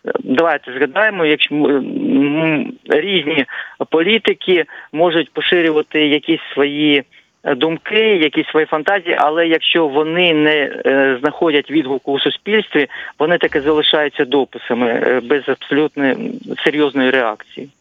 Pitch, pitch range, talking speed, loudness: 150 Hz, 140-165 Hz, 100 wpm, -15 LUFS